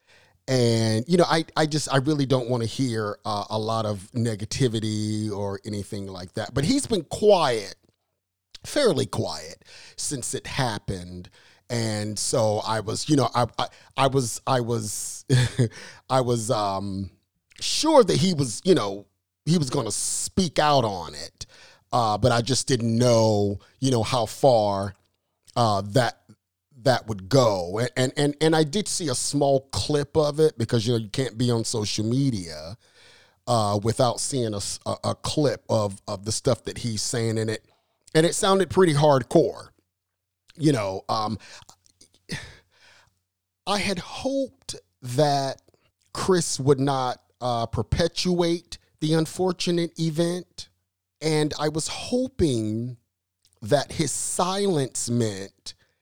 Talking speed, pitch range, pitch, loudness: 150 wpm, 105-145 Hz, 120 Hz, -24 LUFS